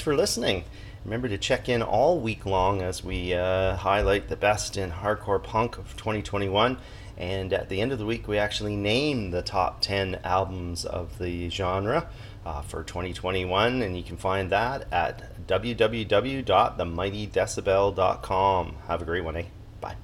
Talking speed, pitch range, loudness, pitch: 160 wpm, 90-105 Hz, -27 LUFS, 100 Hz